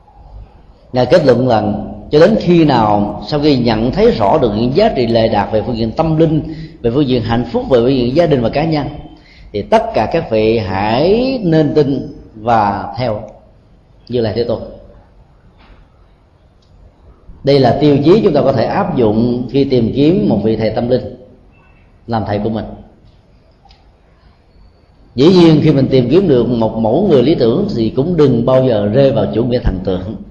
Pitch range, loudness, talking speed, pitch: 105-140 Hz, -13 LUFS, 190 wpm, 115 Hz